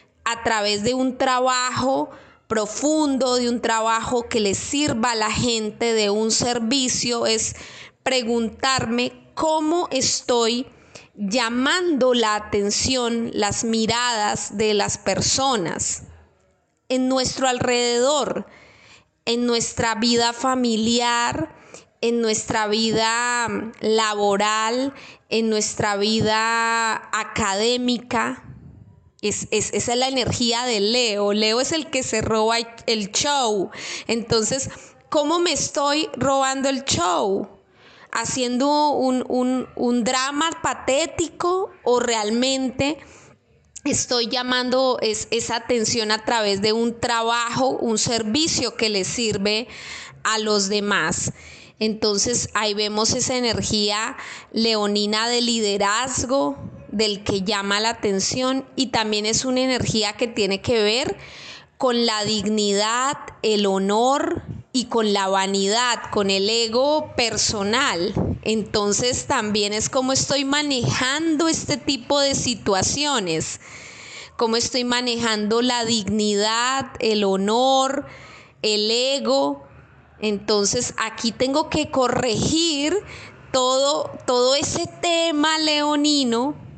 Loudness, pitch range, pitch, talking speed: -21 LUFS, 215-260 Hz, 235 Hz, 110 wpm